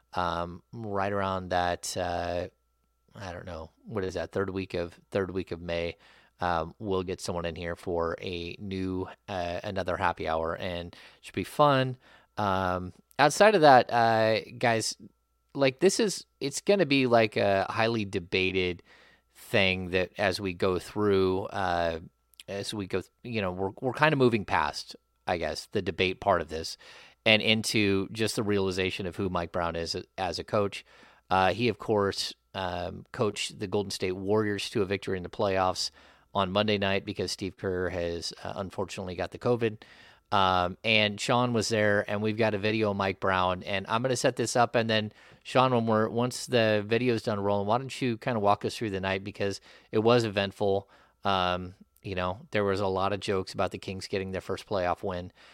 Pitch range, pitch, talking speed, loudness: 90-110 Hz, 100 Hz, 195 wpm, -28 LUFS